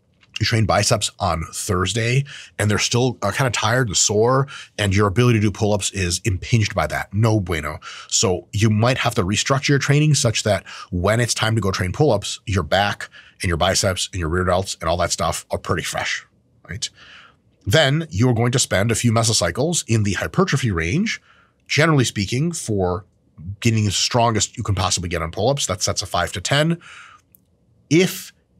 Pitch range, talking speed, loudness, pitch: 95-125 Hz, 190 wpm, -19 LUFS, 110 Hz